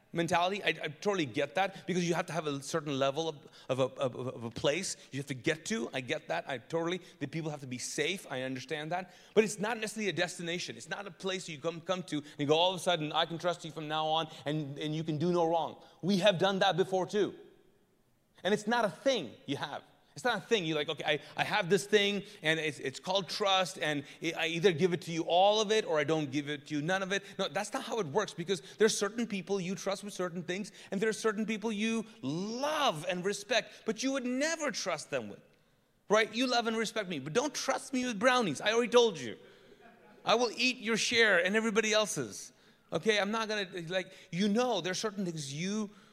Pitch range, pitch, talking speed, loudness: 160-215 Hz, 185 Hz, 255 wpm, -32 LUFS